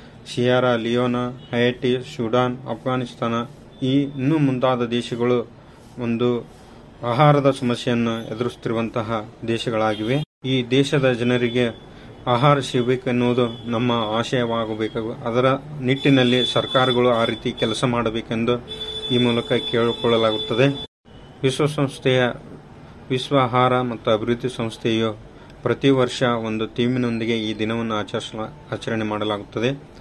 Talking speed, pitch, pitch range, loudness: 90 wpm, 120 Hz, 115-130 Hz, -21 LUFS